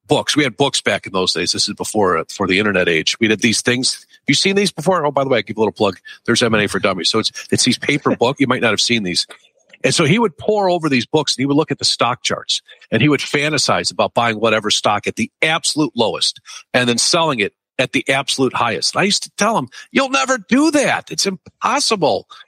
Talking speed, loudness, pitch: 260 wpm, -16 LUFS, 140 Hz